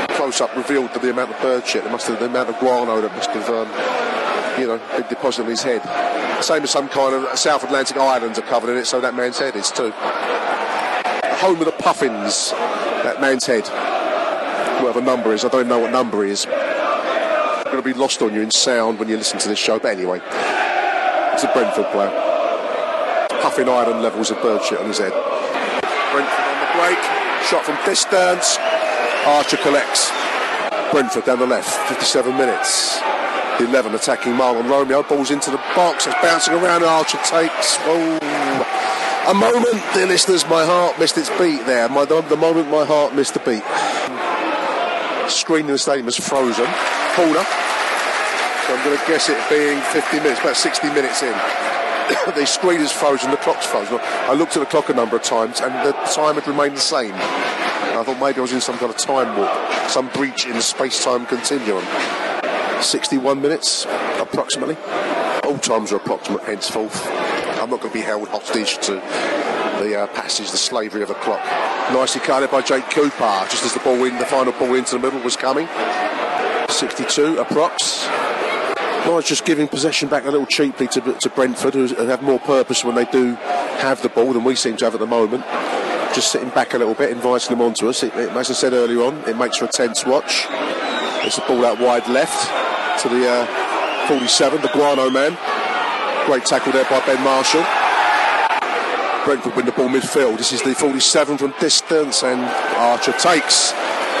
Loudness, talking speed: -18 LUFS, 190 wpm